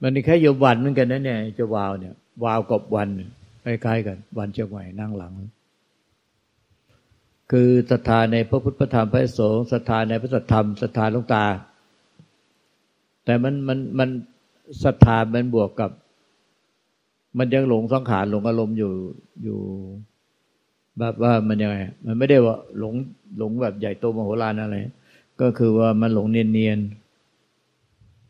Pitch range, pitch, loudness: 105-125 Hz, 115 Hz, -21 LUFS